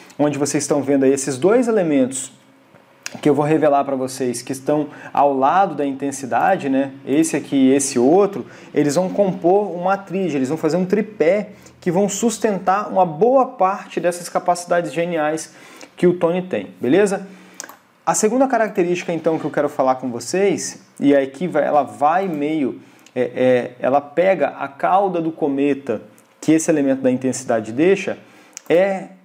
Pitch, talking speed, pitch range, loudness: 160 Hz, 165 wpm, 140-190 Hz, -18 LUFS